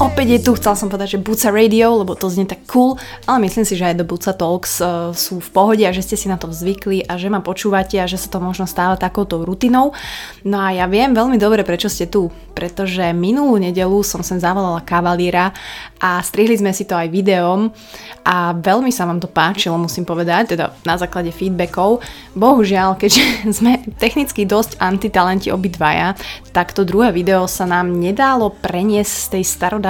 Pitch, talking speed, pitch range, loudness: 190 Hz, 195 wpm, 180-210 Hz, -16 LUFS